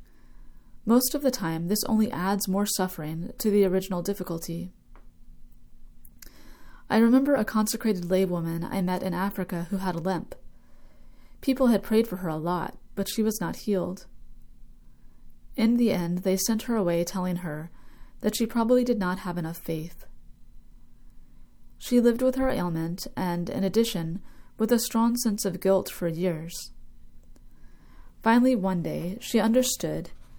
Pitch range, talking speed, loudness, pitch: 165-220 Hz, 150 wpm, -26 LUFS, 185 Hz